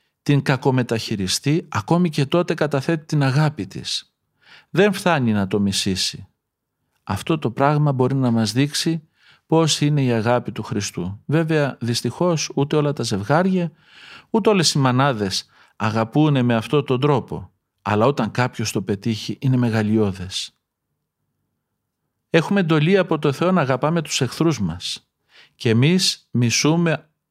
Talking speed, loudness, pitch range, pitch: 135 wpm, -20 LUFS, 115-160 Hz, 140 Hz